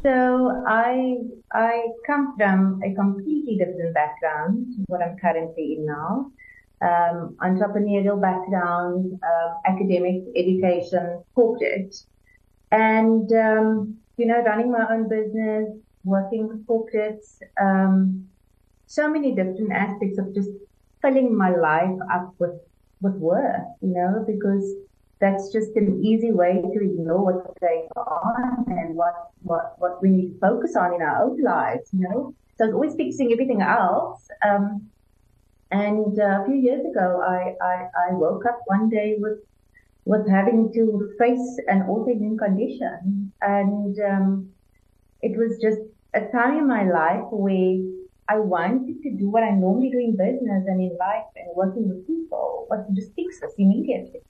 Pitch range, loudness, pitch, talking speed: 185-230 Hz, -22 LUFS, 200 Hz, 150 wpm